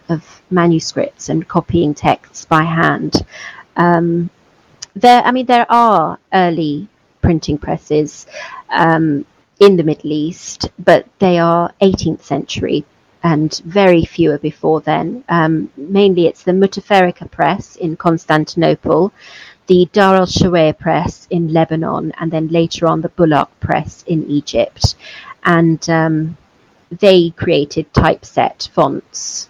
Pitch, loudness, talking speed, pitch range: 170 Hz, -14 LUFS, 125 wpm, 160-185 Hz